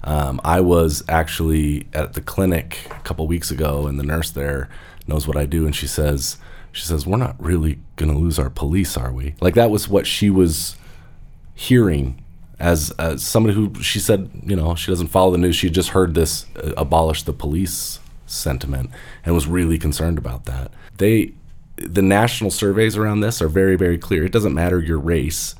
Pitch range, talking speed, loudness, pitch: 75-95 Hz, 200 wpm, -19 LUFS, 80 Hz